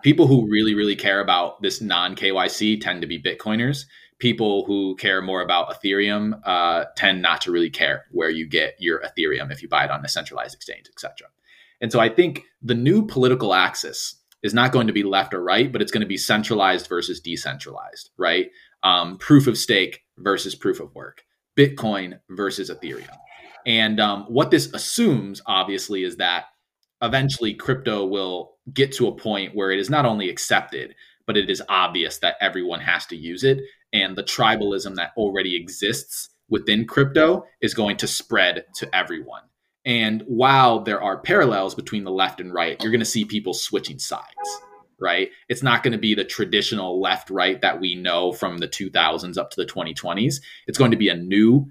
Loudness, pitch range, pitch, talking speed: -21 LUFS, 100-135 Hz, 110 Hz, 190 wpm